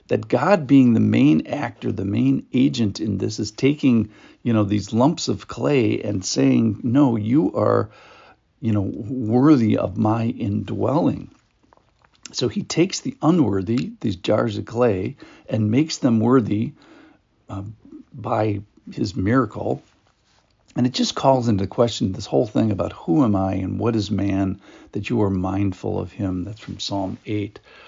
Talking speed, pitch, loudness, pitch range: 160 wpm, 110 Hz, -21 LUFS, 100-125 Hz